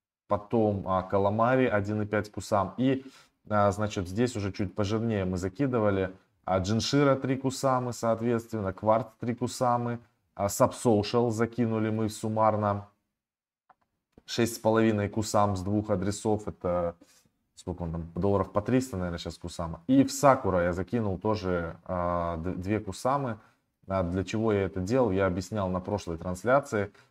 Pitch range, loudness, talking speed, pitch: 95-115 Hz, -28 LUFS, 140 wpm, 105 Hz